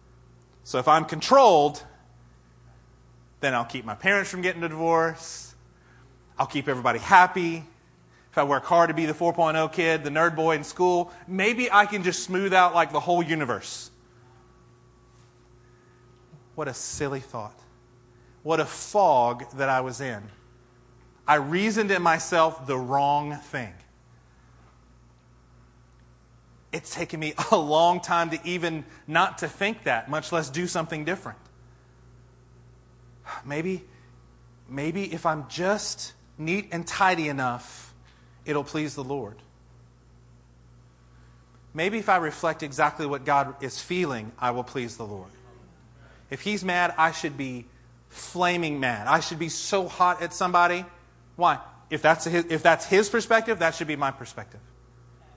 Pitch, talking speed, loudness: 145 Hz, 140 wpm, -24 LUFS